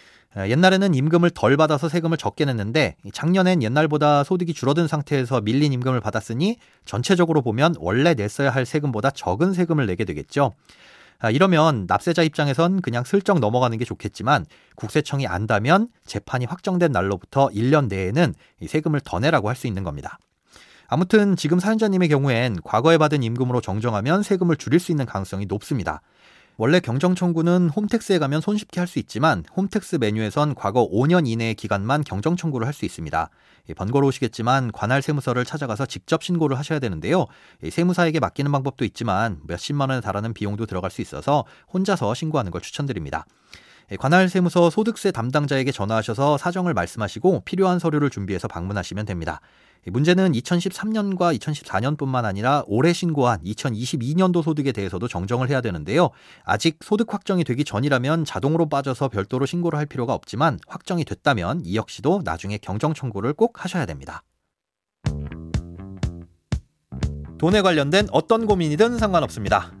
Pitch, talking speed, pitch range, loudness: 140 Hz, 385 characters per minute, 110-170 Hz, -22 LUFS